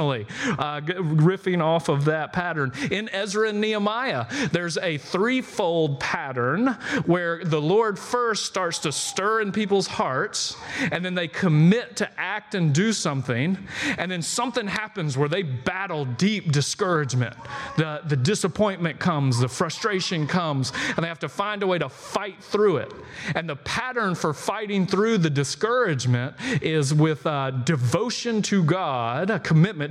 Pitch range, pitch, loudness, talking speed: 150-205 Hz, 175 Hz, -24 LUFS, 155 wpm